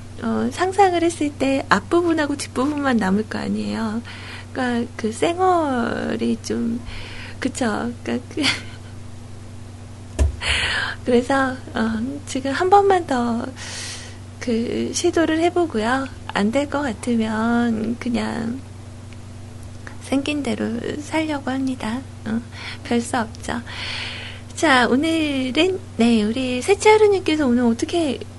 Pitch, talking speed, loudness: 230 Hz, 210 characters per minute, -21 LUFS